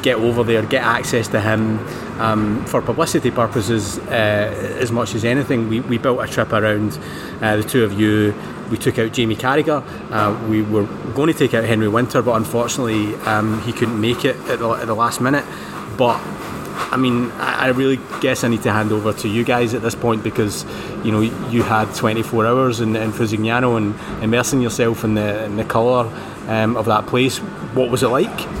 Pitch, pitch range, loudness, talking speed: 115 Hz, 110-120 Hz, -18 LUFS, 205 wpm